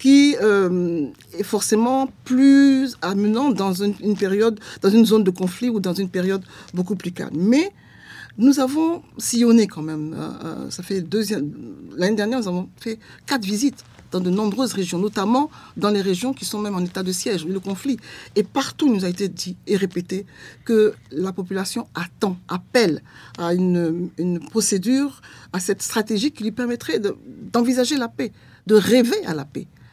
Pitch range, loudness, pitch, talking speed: 185-240 Hz, -21 LUFS, 205 Hz, 175 wpm